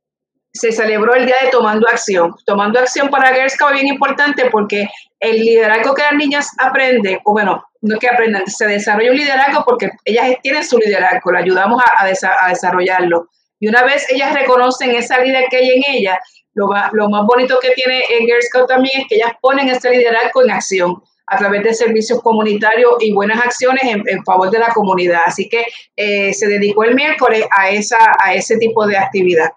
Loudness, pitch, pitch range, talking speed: -12 LUFS, 230 Hz, 205-255 Hz, 205 wpm